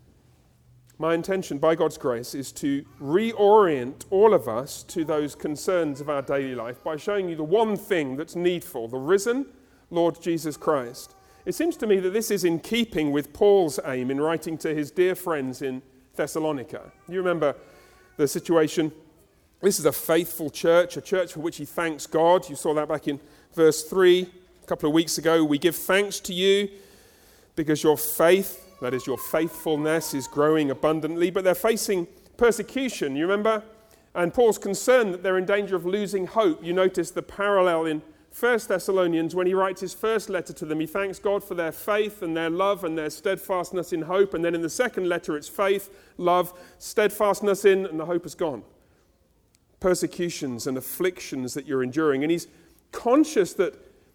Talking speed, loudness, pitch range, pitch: 185 wpm, -24 LUFS, 155-195 Hz, 175 Hz